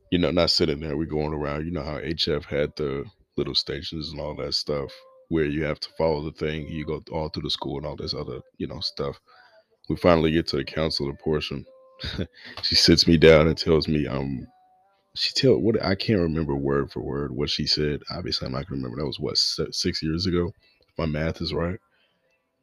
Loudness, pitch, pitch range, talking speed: -24 LUFS, 80 Hz, 75-85 Hz, 220 wpm